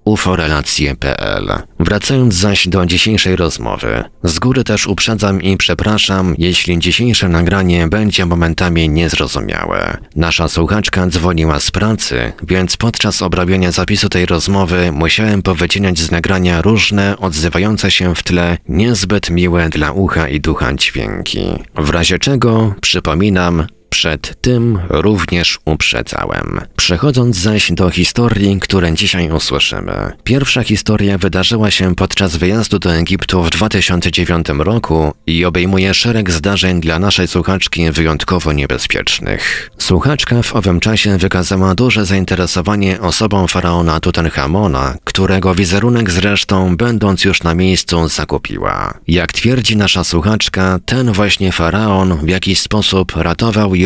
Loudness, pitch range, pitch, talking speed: -12 LUFS, 85-105 Hz, 95 Hz, 125 wpm